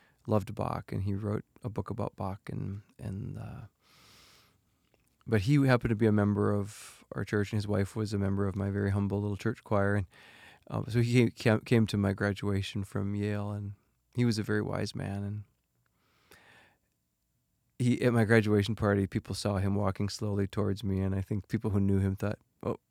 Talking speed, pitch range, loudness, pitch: 195 wpm, 100-110 Hz, -31 LUFS, 105 Hz